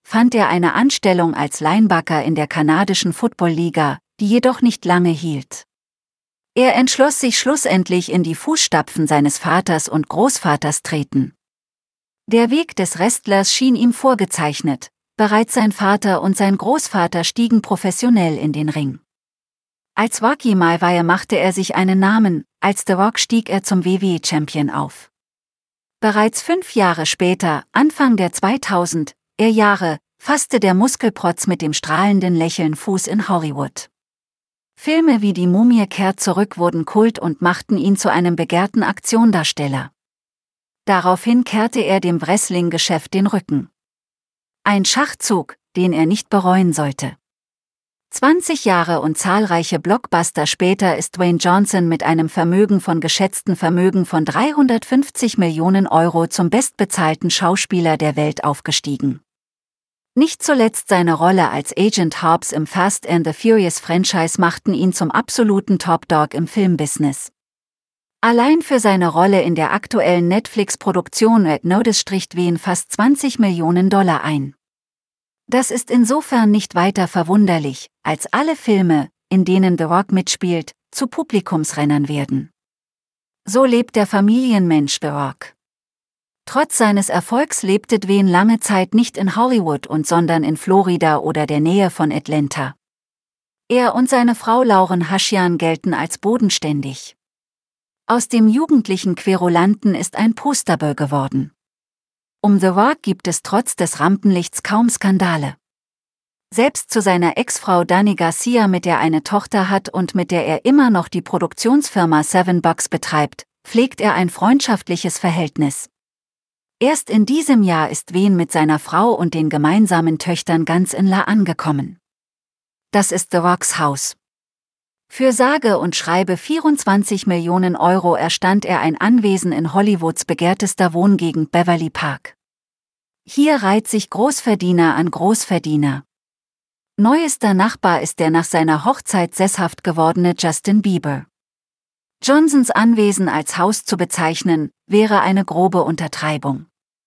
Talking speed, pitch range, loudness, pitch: 135 wpm, 165-215 Hz, -16 LUFS, 185 Hz